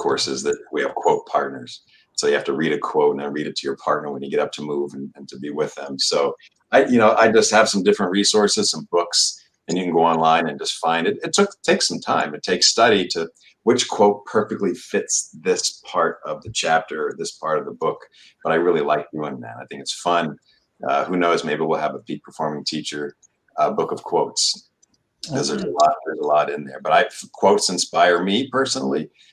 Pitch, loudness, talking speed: 100 Hz, -20 LUFS, 235 wpm